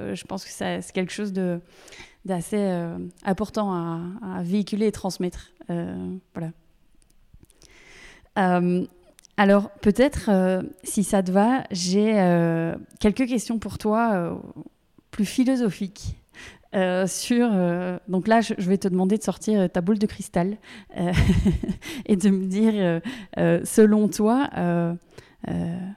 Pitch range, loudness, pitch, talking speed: 180-215 Hz, -23 LUFS, 195 Hz, 140 wpm